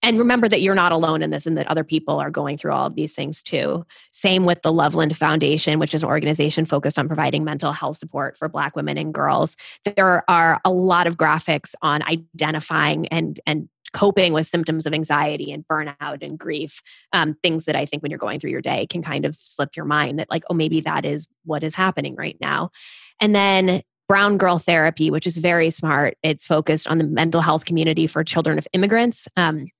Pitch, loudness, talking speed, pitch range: 160 Hz, -20 LUFS, 215 wpm, 155-175 Hz